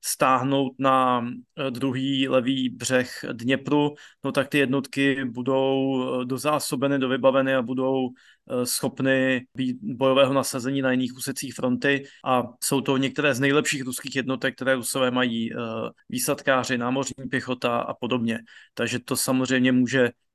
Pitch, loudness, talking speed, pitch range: 130 Hz, -24 LUFS, 125 wpm, 125-135 Hz